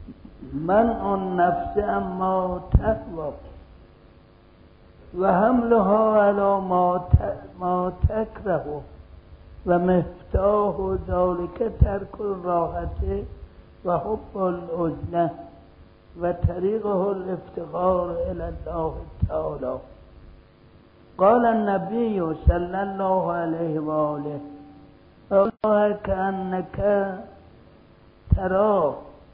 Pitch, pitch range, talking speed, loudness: 185 Hz, 165-200 Hz, 60 wpm, -24 LUFS